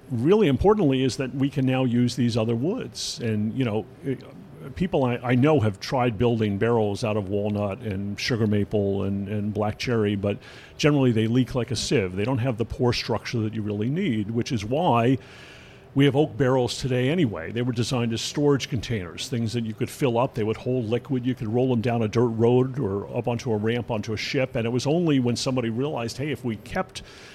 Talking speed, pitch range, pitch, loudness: 220 wpm, 110-130 Hz, 120 Hz, -24 LUFS